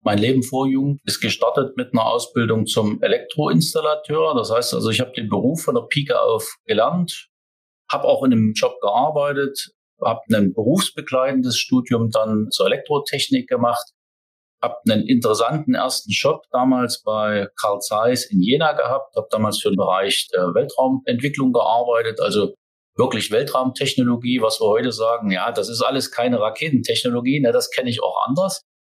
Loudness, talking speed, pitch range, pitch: -19 LUFS, 160 wpm, 115-160 Hz, 130 Hz